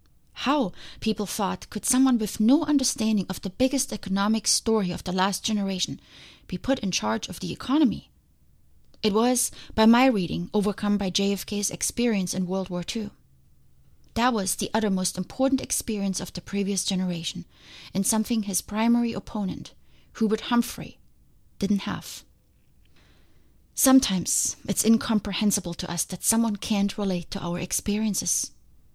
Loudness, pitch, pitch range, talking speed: -25 LUFS, 200 Hz, 180-220 Hz, 140 wpm